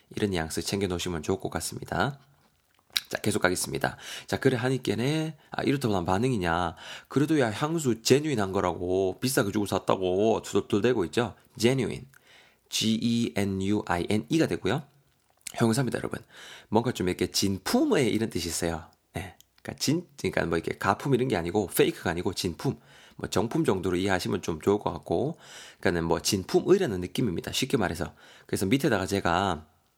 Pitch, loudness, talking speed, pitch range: 100 Hz, -28 LUFS, 390 characters per minute, 90-125 Hz